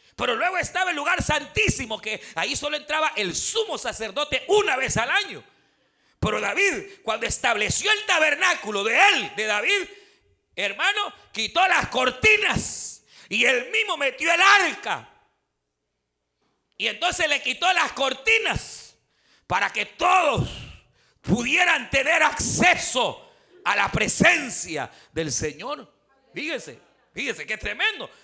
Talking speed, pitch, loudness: 125 wpm, 345 Hz, -22 LUFS